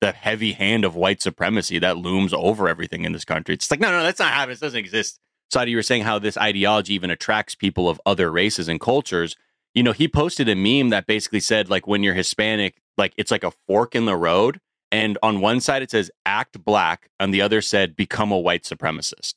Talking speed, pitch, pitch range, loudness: 230 wpm, 105 Hz, 95-110 Hz, -21 LUFS